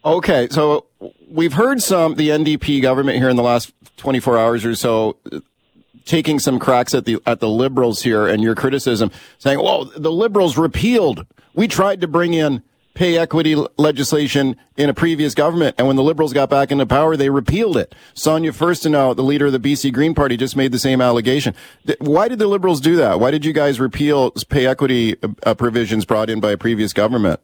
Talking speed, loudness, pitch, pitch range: 200 wpm, -16 LUFS, 140 Hz, 120-155 Hz